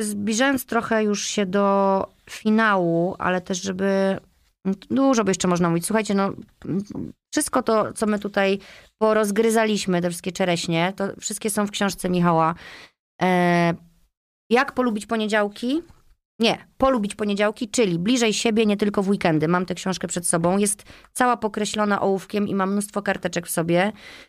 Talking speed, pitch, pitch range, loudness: 145 wpm, 200 Hz, 185-220 Hz, -22 LUFS